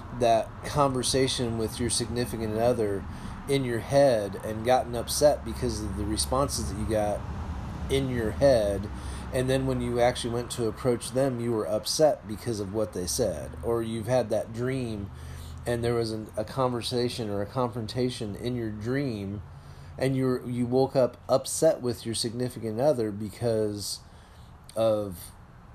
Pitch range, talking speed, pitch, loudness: 105-125 Hz, 160 wpm, 115 Hz, -28 LUFS